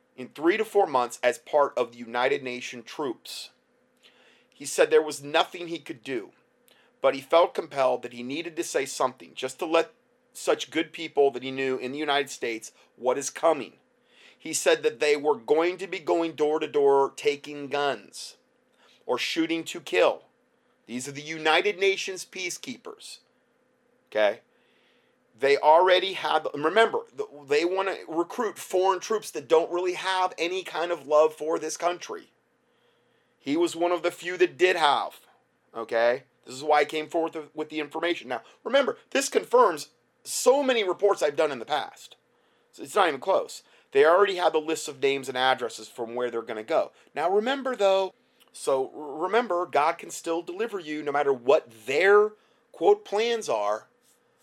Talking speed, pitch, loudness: 175 wpm, 170 Hz, -26 LUFS